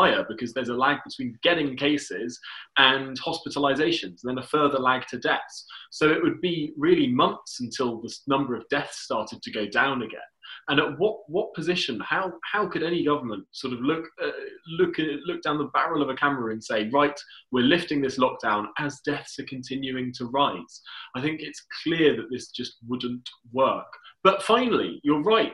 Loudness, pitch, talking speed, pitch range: -25 LUFS, 145 Hz, 190 wpm, 130-165 Hz